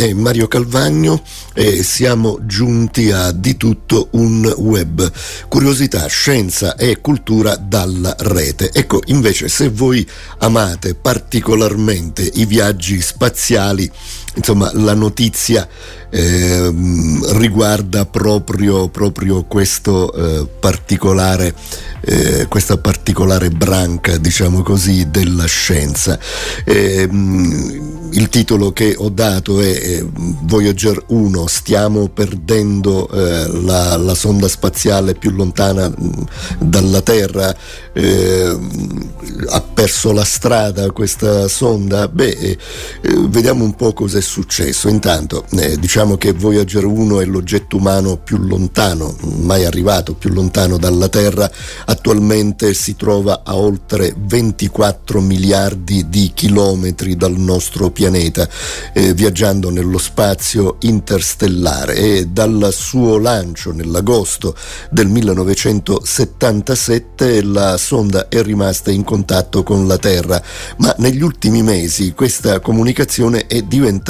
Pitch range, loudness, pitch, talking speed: 90-105 Hz, -13 LUFS, 100 Hz, 110 wpm